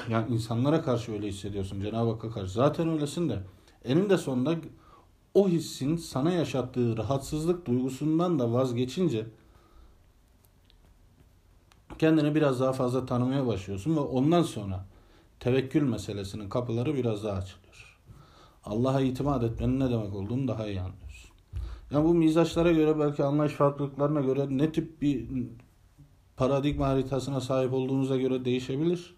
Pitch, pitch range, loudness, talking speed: 130 Hz, 105-145 Hz, -28 LUFS, 125 wpm